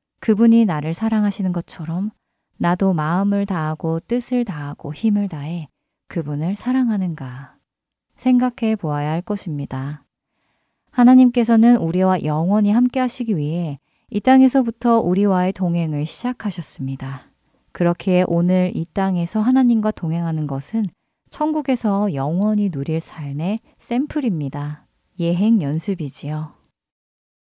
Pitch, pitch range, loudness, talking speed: 185 Hz, 155-225 Hz, -19 LUFS, 285 characters per minute